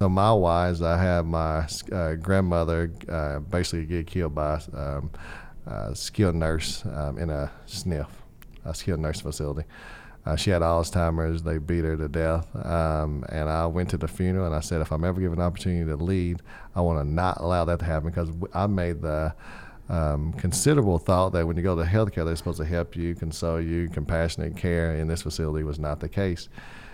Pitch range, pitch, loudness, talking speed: 80-90 Hz, 85 Hz, -27 LUFS, 200 wpm